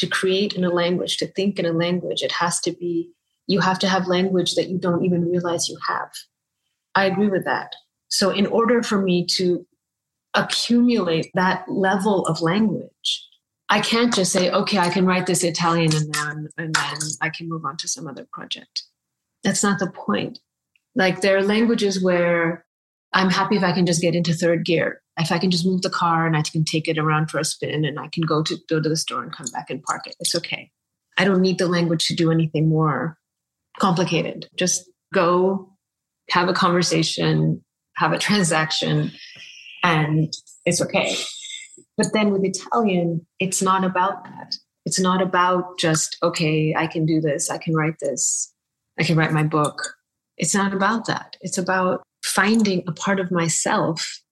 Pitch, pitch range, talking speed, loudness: 175 Hz, 165-190 Hz, 190 wpm, -21 LUFS